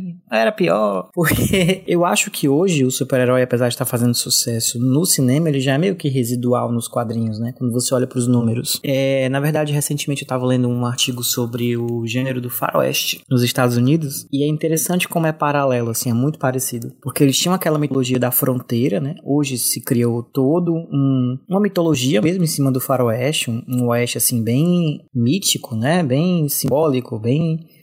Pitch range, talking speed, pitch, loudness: 125-150 Hz, 185 wpm, 130 Hz, -18 LUFS